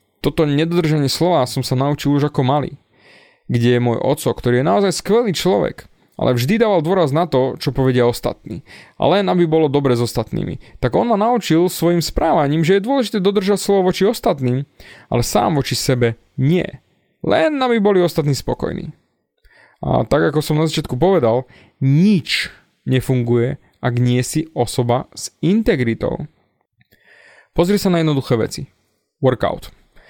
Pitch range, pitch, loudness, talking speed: 125-180 Hz, 145 Hz, -17 LUFS, 155 wpm